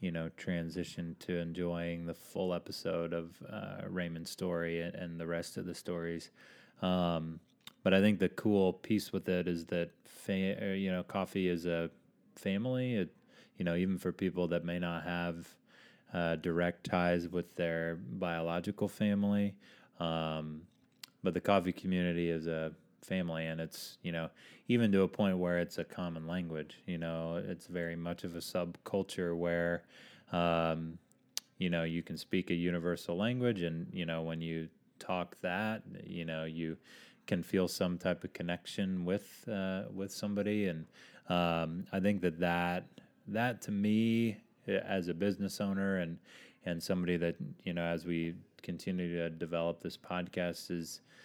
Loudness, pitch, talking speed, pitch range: -36 LUFS, 85 Hz, 165 wpm, 85-95 Hz